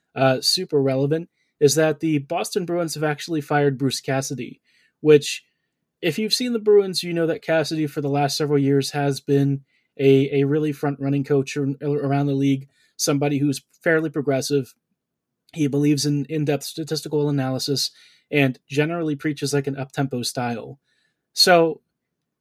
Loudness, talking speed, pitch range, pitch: -21 LUFS, 155 wpm, 140-155 Hz, 145 Hz